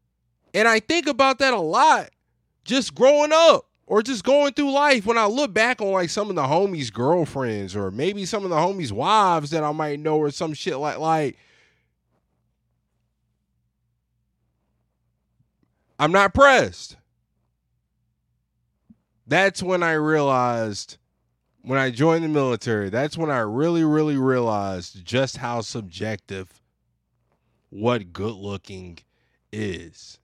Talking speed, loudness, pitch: 135 wpm, -21 LUFS, 140 Hz